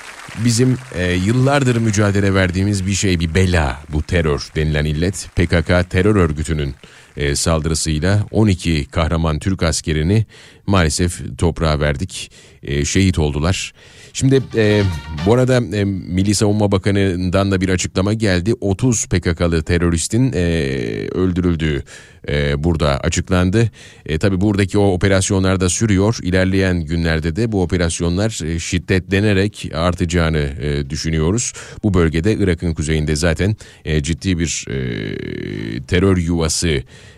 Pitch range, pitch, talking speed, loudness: 80-100 Hz, 90 Hz, 125 wpm, -17 LUFS